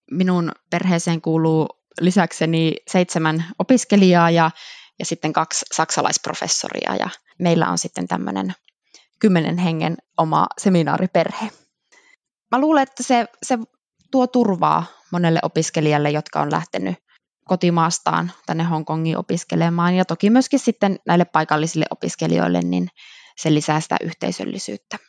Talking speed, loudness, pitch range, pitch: 115 wpm, -20 LUFS, 155-200 Hz, 170 Hz